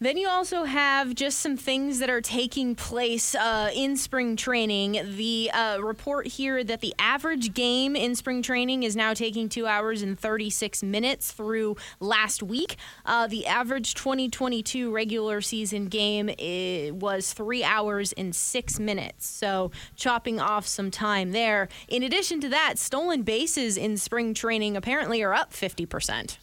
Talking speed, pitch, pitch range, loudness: 160 wpm, 225 Hz, 210-260 Hz, -26 LUFS